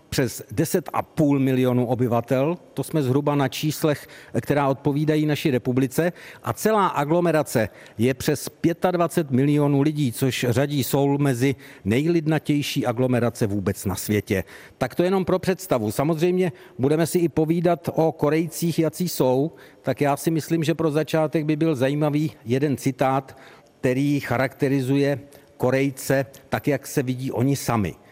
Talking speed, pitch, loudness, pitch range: 140 wpm, 140 Hz, -23 LUFS, 130-160 Hz